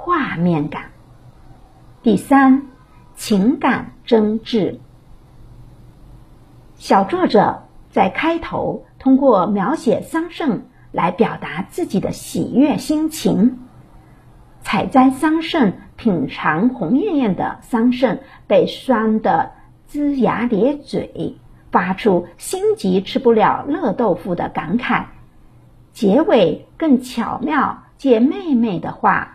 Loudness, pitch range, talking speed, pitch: -17 LUFS, 220-290 Hz, 150 characters per minute, 255 Hz